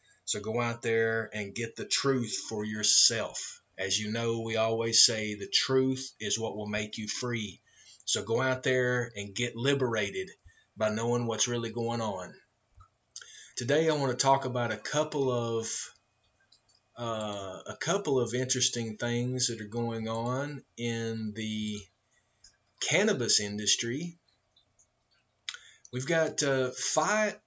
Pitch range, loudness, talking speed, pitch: 110-130 Hz, -30 LUFS, 140 wpm, 115 Hz